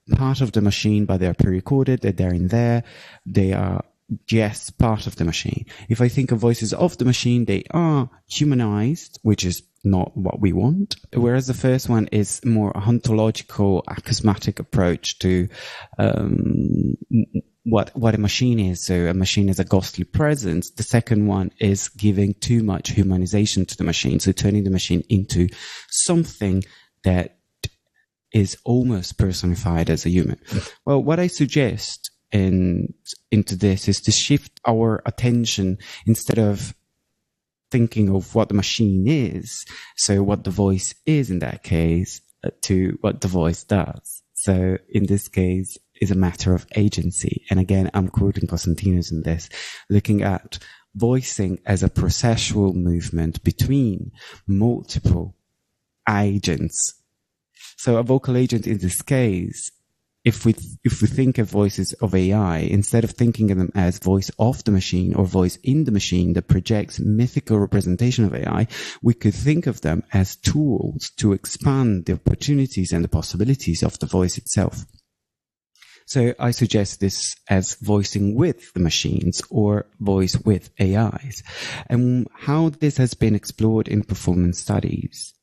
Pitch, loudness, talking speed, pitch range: 105 Hz, -21 LUFS, 155 wpm, 95-120 Hz